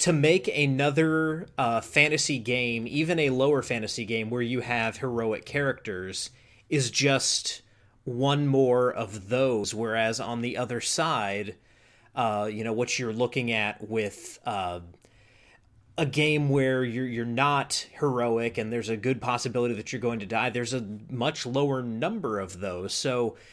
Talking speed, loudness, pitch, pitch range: 155 wpm, -27 LUFS, 120 Hz, 110-135 Hz